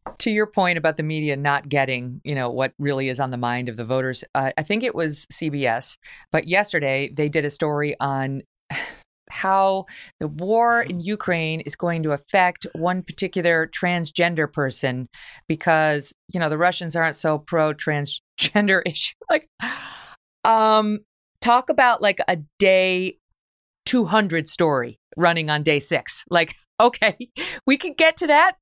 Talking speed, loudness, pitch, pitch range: 155 wpm, -21 LUFS, 165 Hz, 145-195 Hz